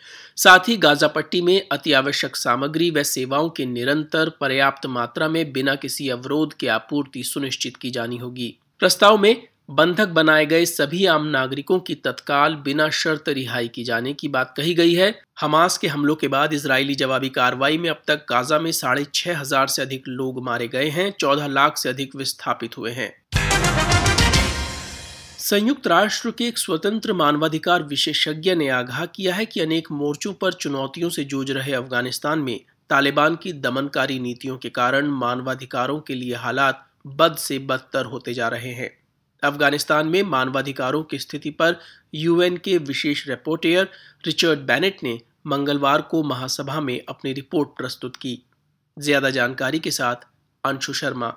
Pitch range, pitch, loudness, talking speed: 130-160 Hz, 145 Hz, -20 LUFS, 160 wpm